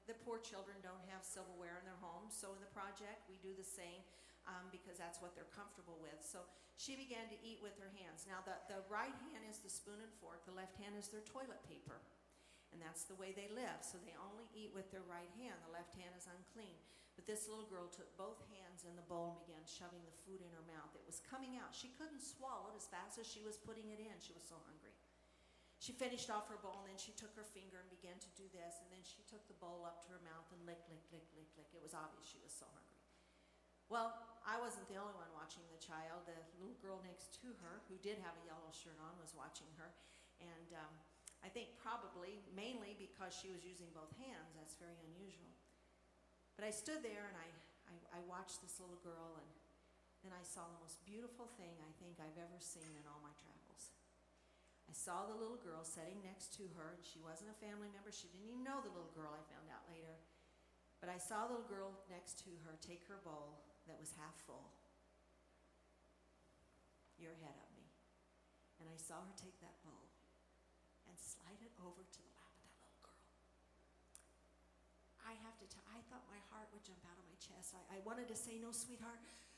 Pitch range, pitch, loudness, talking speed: 160-205 Hz, 180 Hz, -54 LUFS, 225 wpm